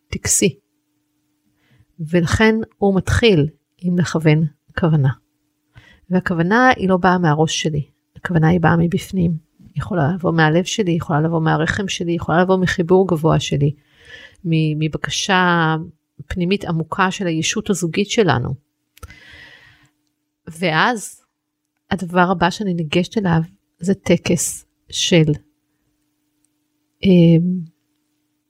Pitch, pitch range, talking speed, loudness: 160 Hz, 150-180 Hz, 100 wpm, -17 LUFS